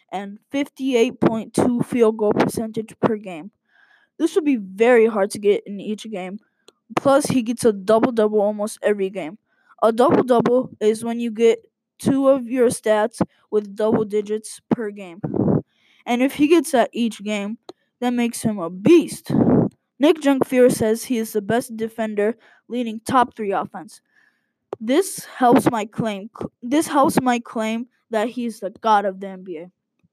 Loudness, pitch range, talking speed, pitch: -20 LUFS, 210-250 Hz, 160 wpm, 225 Hz